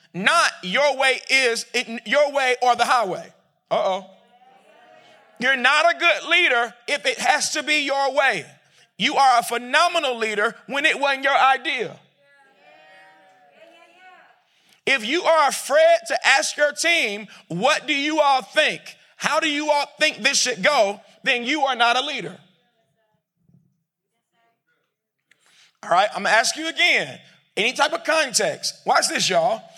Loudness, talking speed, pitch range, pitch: -19 LUFS, 150 wpm, 230-305 Hz, 270 Hz